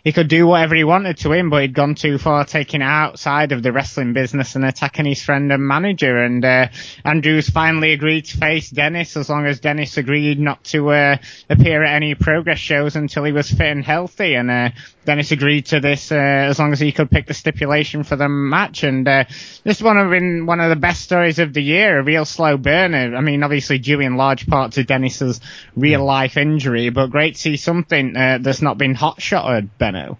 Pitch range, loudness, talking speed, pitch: 135-155 Hz, -16 LUFS, 220 wpm, 145 Hz